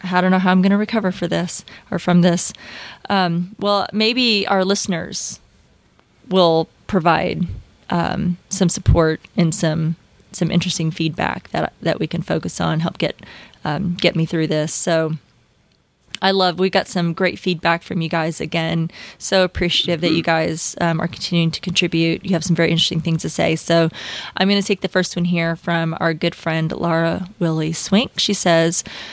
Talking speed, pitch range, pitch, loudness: 185 wpm, 165-185 Hz, 175 Hz, -19 LUFS